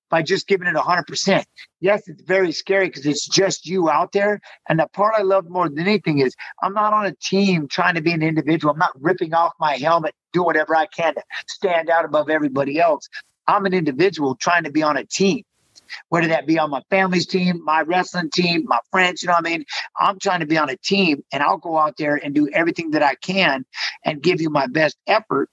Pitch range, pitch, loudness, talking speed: 155-190 Hz, 170 Hz, -19 LUFS, 235 wpm